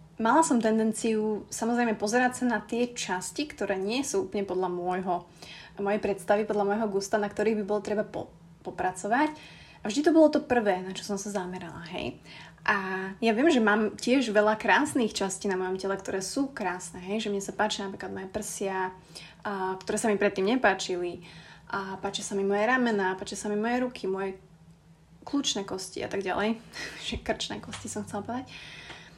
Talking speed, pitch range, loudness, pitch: 185 wpm, 185-220 Hz, -28 LUFS, 205 Hz